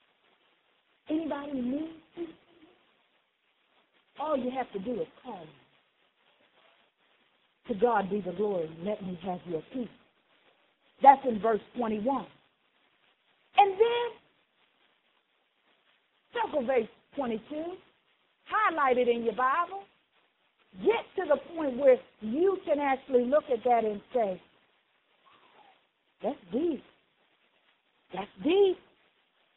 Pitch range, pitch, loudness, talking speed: 230-330 Hz, 270 Hz, -29 LUFS, 105 wpm